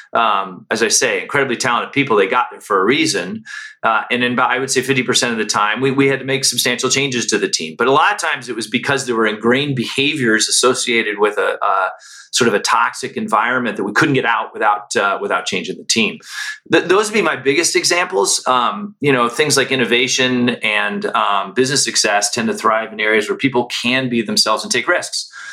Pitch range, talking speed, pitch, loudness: 120-155 Hz, 225 wpm, 130 Hz, -15 LUFS